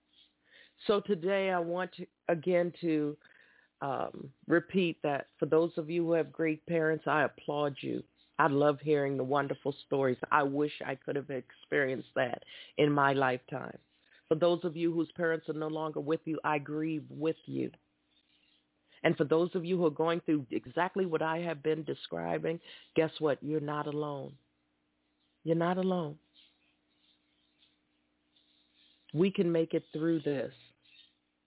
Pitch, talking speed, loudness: 150 Hz, 155 wpm, -32 LUFS